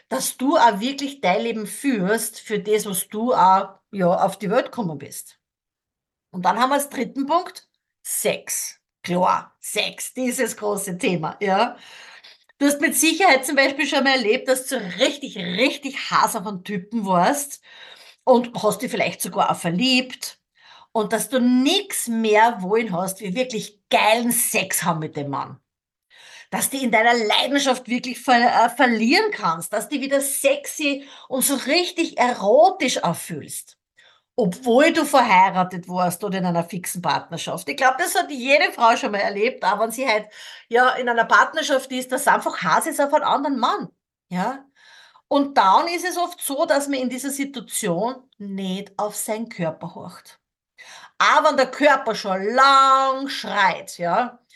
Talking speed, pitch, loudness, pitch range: 165 wpm, 240 Hz, -20 LUFS, 205-275 Hz